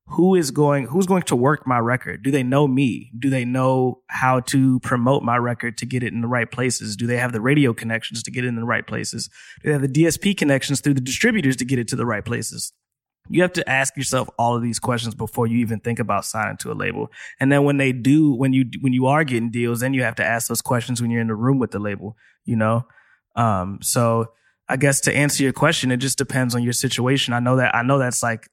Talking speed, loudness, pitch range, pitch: 265 wpm, -20 LUFS, 115-135 Hz, 125 Hz